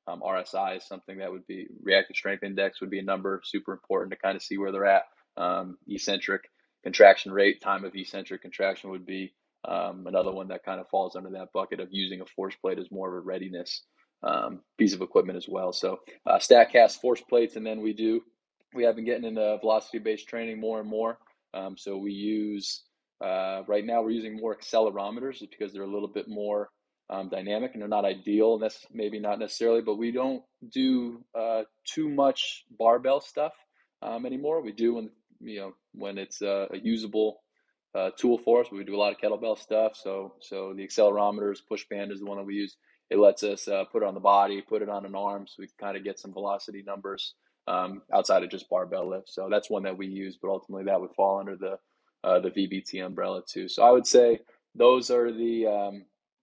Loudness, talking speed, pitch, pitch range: -27 LUFS, 220 wpm, 105 Hz, 95-115 Hz